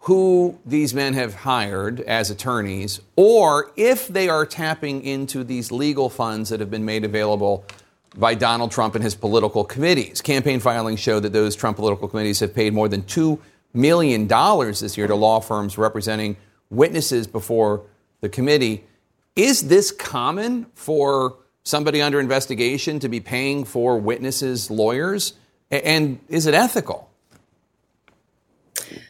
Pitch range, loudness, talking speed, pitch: 110-145 Hz, -20 LUFS, 140 wpm, 120 Hz